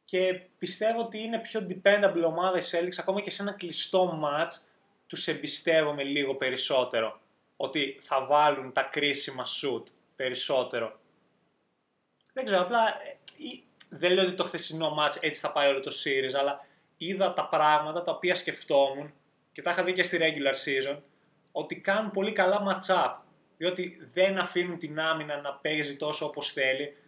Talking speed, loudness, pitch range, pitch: 160 wpm, -28 LUFS, 145-185 Hz, 165 Hz